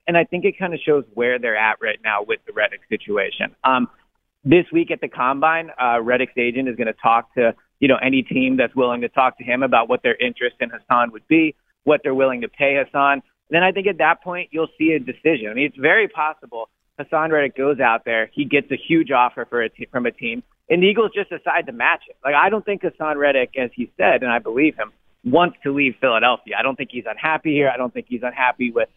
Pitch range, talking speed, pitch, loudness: 125-170 Hz, 255 wpm, 145 Hz, -19 LUFS